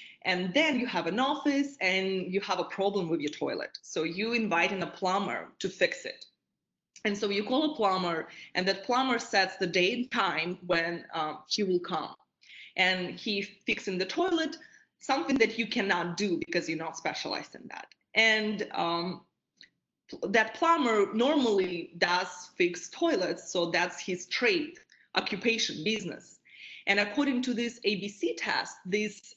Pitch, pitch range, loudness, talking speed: 200 Hz, 180-240 Hz, -29 LUFS, 160 wpm